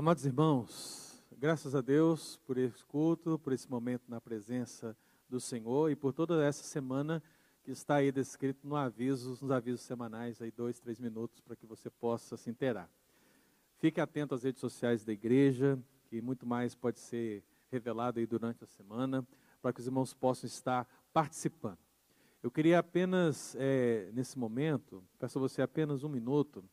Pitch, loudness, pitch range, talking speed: 130 Hz, -35 LUFS, 120-140 Hz, 170 wpm